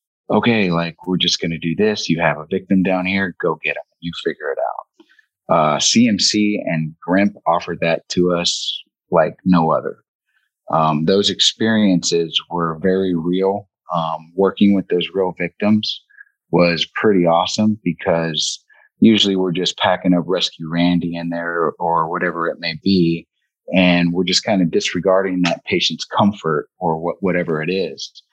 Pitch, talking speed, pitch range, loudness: 90 Hz, 165 wpm, 85-95 Hz, -17 LUFS